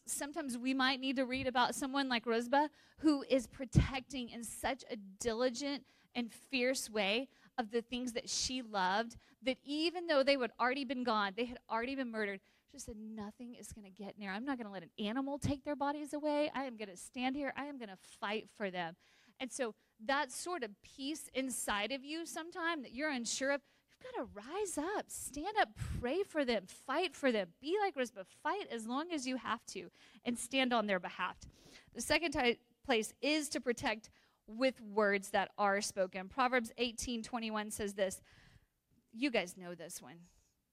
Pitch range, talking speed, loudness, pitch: 215-280 Hz, 200 wpm, -37 LUFS, 250 Hz